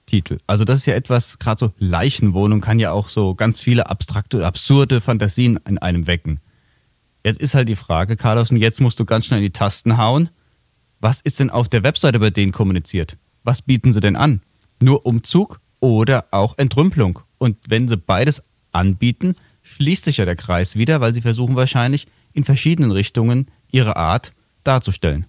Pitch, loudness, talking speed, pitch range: 115 Hz, -17 LUFS, 185 wpm, 100-130 Hz